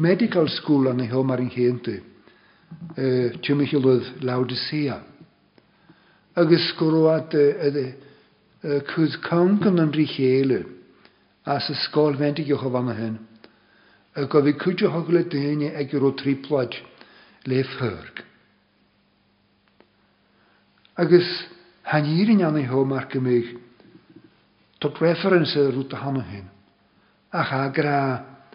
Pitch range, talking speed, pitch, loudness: 130-165 Hz, 115 wpm, 145 Hz, -22 LUFS